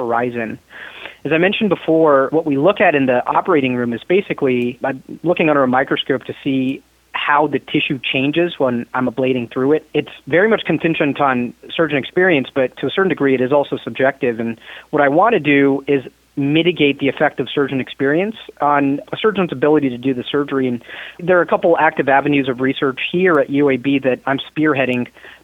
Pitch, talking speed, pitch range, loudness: 140 Hz, 195 wpm, 130-155 Hz, -16 LUFS